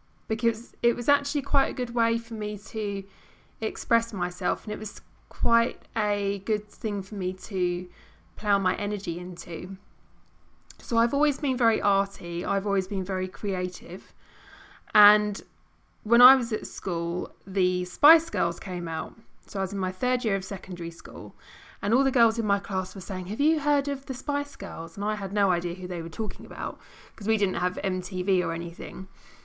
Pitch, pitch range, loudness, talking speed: 200 Hz, 185-230 Hz, -27 LUFS, 185 wpm